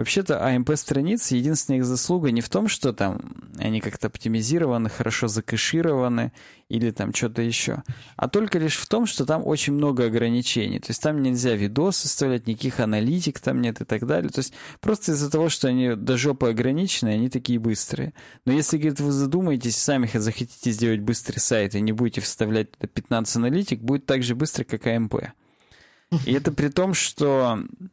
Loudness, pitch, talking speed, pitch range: -23 LUFS, 125 Hz, 175 wpm, 115-150 Hz